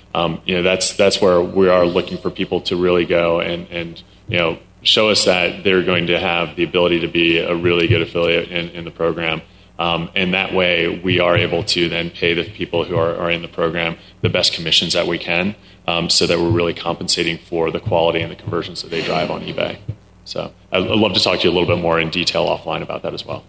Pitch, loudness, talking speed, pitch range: 85 Hz, -17 LUFS, 245 wpm, 85-90 Hz